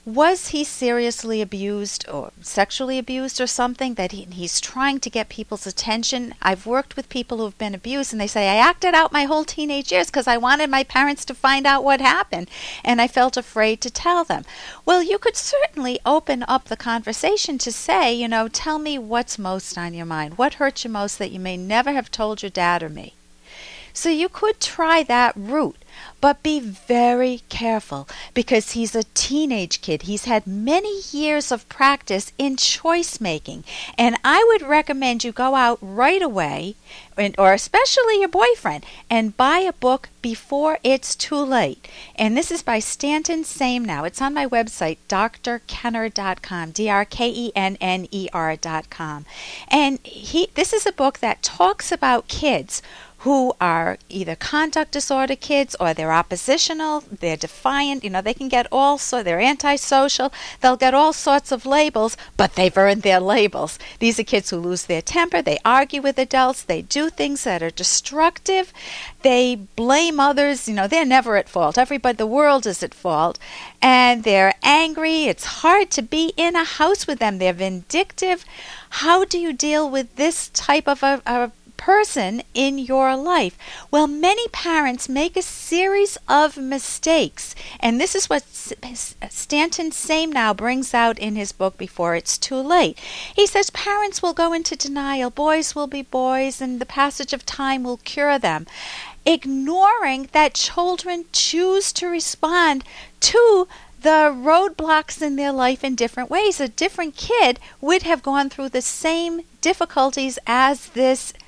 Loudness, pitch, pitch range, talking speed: -19 LUFS, 265 Hz, 225-310 Hz, 175 wpm